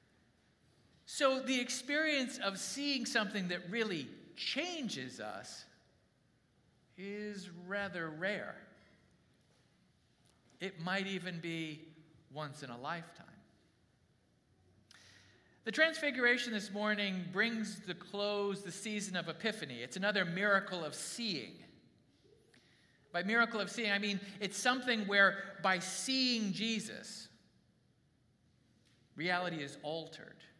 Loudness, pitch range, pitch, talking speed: -36 LUFS, 165-220 Hz, 195 Hz, 105 wpm